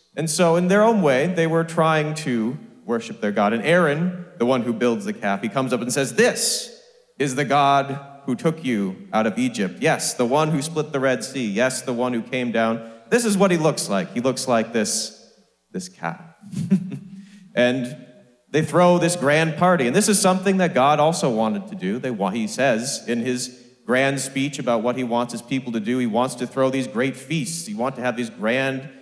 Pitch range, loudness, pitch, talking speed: 125-175 Hz, -21 LUFS, 140 Hz, 220 wpm